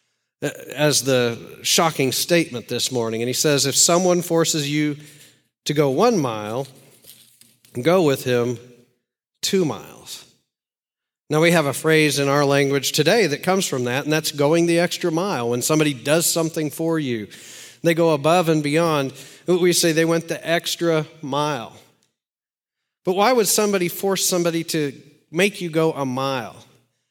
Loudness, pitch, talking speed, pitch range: -20 LUFS, 150 Hz, 155 wpm, 135-170 Hz